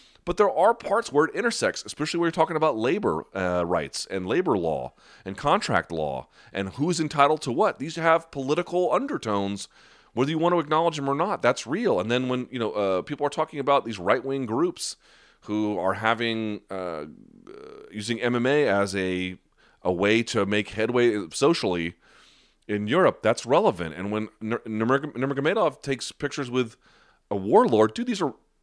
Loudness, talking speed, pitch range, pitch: -25 LUFS, 175 wpm, 105-150 Hz, 120 Hz